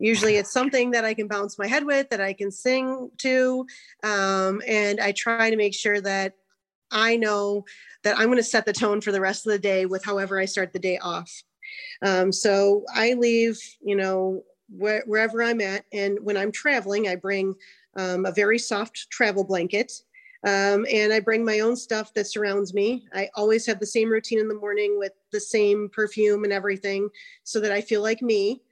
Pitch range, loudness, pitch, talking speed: 200-225 Hz, -24 LUFS, 210 Hz, 205 wpm